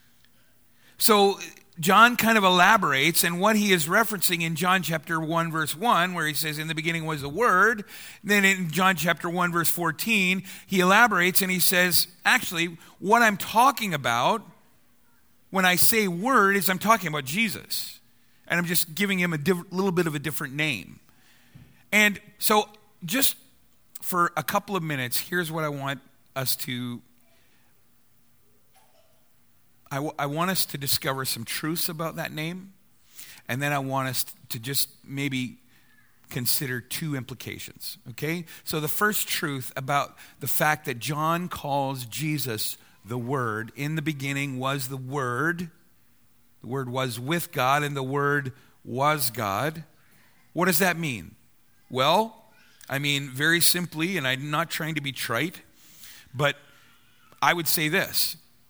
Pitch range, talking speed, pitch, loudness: 140-185 Hz, 155 wpm, 160 Hz, -24 LUFS